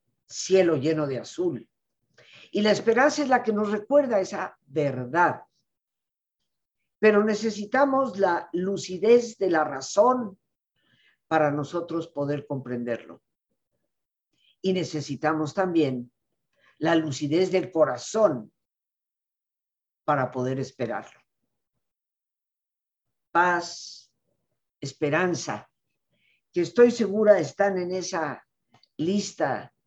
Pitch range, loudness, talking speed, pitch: 150-210 Hz, -25 LUFS, 90 wpm, 175 Hz